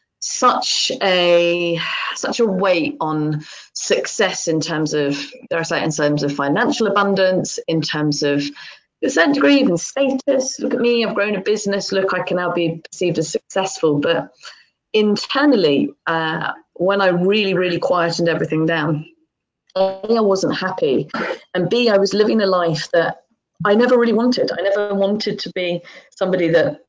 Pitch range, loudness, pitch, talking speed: 165-210 Hz, -18 LUFS, 185 Hz, 165 wpm